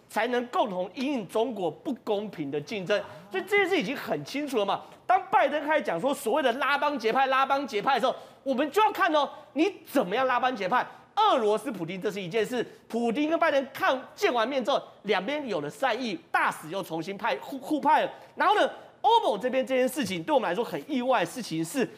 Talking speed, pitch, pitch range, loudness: 330 characters per minute, 260 Hz, 210-295 Hz, -27 LUFS